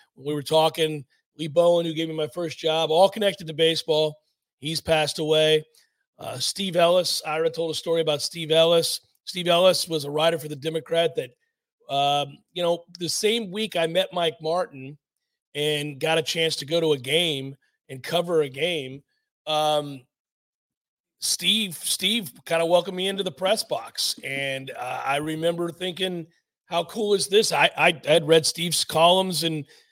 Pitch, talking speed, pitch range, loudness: 165 Hz, 175 wpm, 155-175 Hz, -23 LUFS